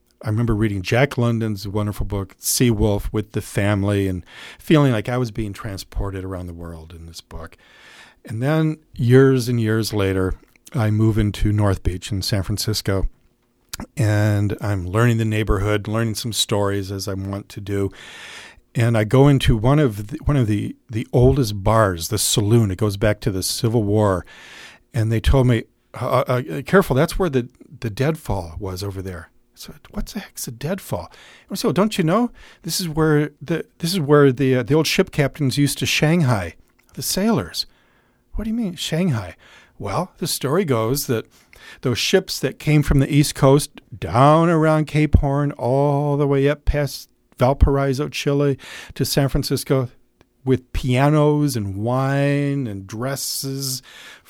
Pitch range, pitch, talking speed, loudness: 105-140 Hz, 120 Hz, 170 wpm, -20 LUFS